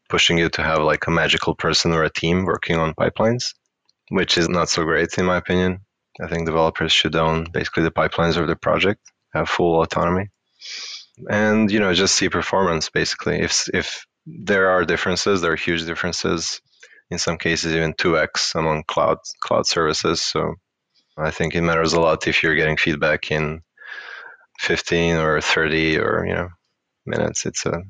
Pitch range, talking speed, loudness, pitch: 80-90 Hz, 180 wpm, -19 LUFS, 85 Hz